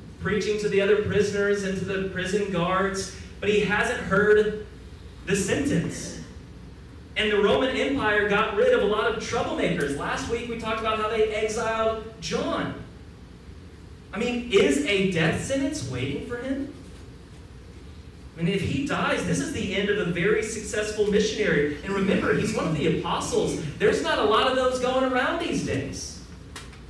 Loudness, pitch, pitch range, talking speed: -25 LUFS, 210 Hz, 195-225 Hz, 170 wpm